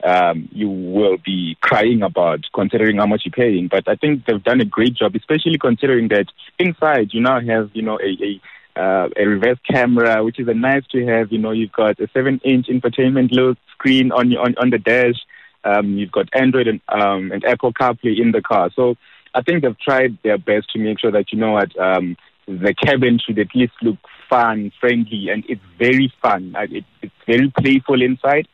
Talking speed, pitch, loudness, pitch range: 205 wpm, 115 Hz, -17 LUFS, 105-130 Hz